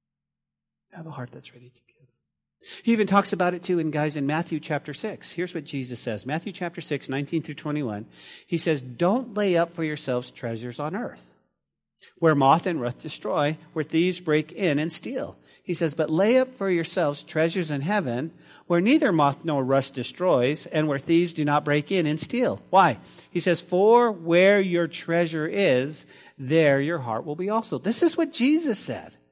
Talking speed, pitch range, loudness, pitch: 190 wpm, 140-180 Hz, -24 LUFS, 160 Hz